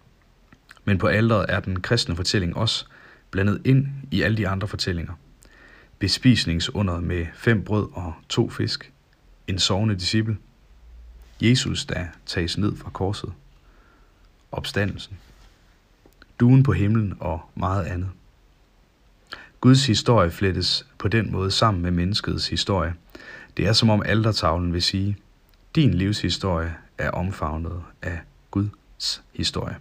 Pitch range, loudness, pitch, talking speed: 85-110 Hz, -23 LUFS, 95 Hz, 125 wpm